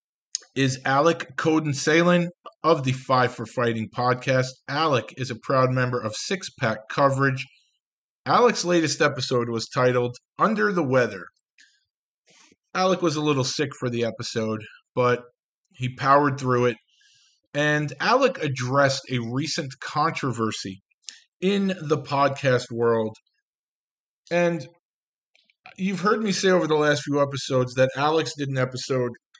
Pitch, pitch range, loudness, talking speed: 135 Hz, 125-160 Hz, -23 LUFS, 135 wpm